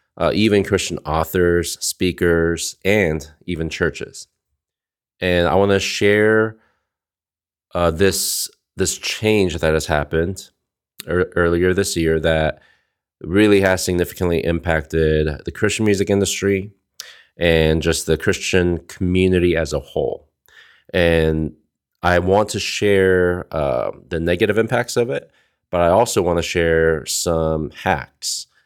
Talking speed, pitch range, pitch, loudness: 125 wpm, 80-100 Hz, 85 Hz, -18 LUFS